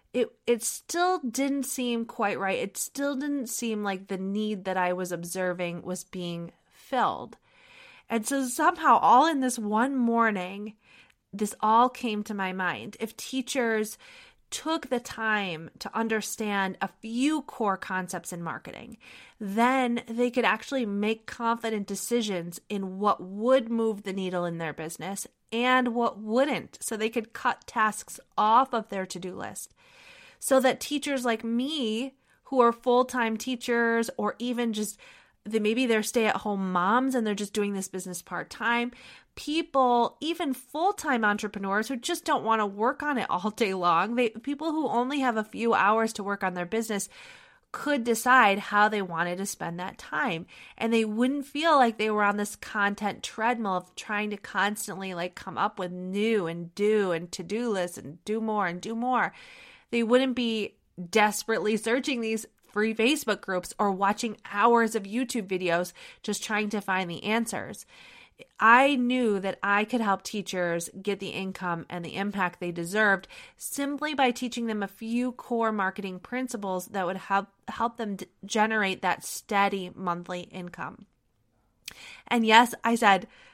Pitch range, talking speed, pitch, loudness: 195-245 Hz, 165 wpm, 220 Hz, -27 LUFS